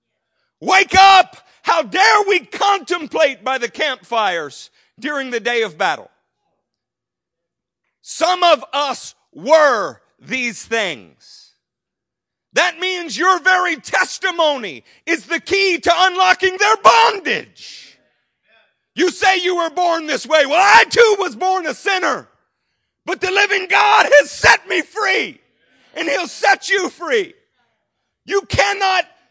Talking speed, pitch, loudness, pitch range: 125 wpm, 360 Hz, -15 LUFS, 305-390 Hz